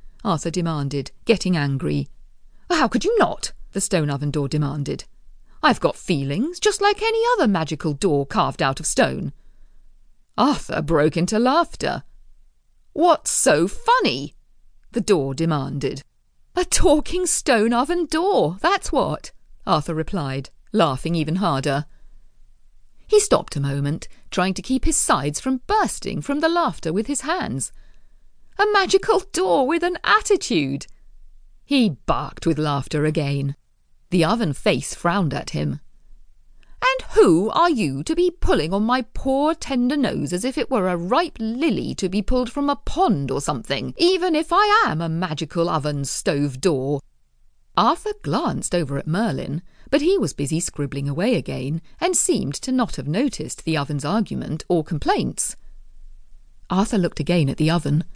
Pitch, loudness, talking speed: 185 Hz, -21 LUFS, 150 wpm